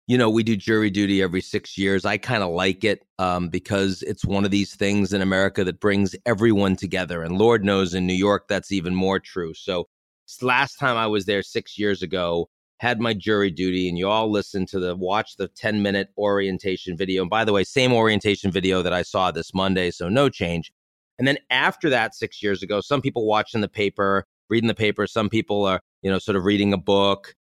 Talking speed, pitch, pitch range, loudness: 220 wpm, 100 Hz, 95-105 Hz, -22 LUFS